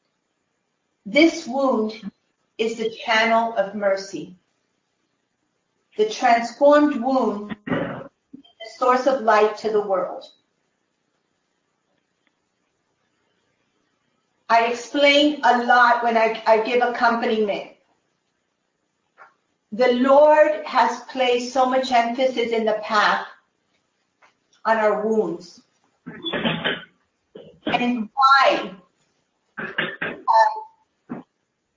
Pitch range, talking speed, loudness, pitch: 220-260 Hz, 80 wpm, -19 LUFS, 235 Hz